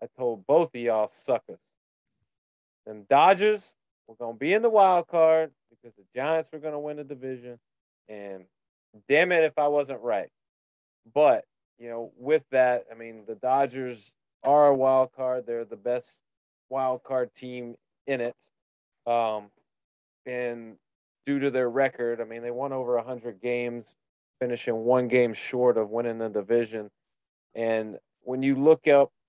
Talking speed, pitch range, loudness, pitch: 165 wpm, 115-140 Hz, -25 LUFS, 125 Hz